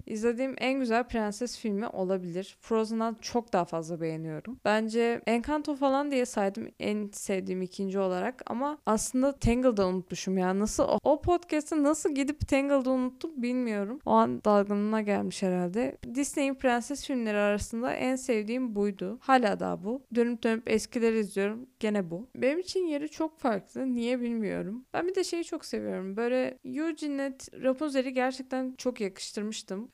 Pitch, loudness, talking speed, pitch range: 235 Hz, -30 LUFS, 150 wpm, 205-270 Hz